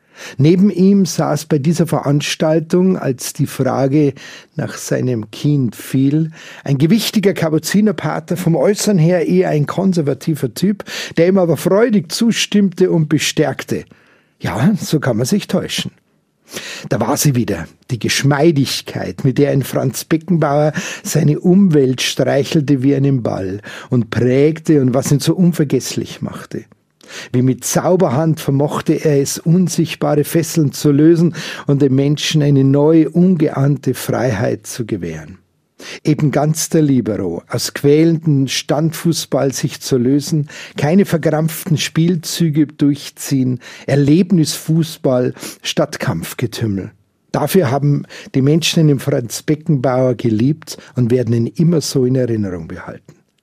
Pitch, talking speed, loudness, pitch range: 150 Hz, 125 wpm, -15 LUFS, 135-165 Hz